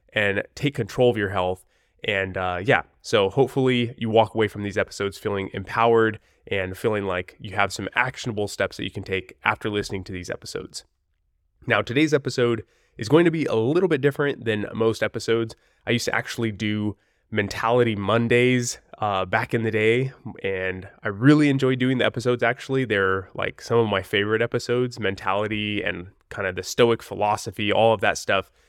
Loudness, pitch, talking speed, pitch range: -23 LUFS, 110 Hz, 185 wpm, 100-120 Hz